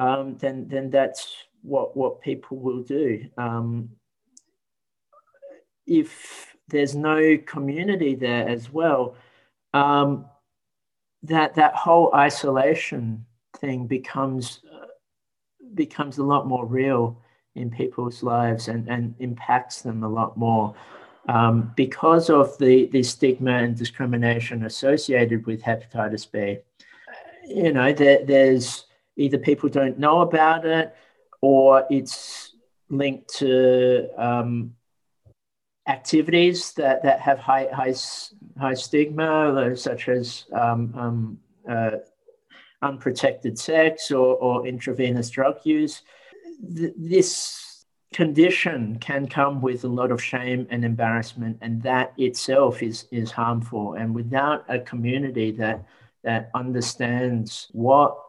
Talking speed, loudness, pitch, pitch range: 115 wpm, -22 LUFS, 130 Hz, 120-145 Hz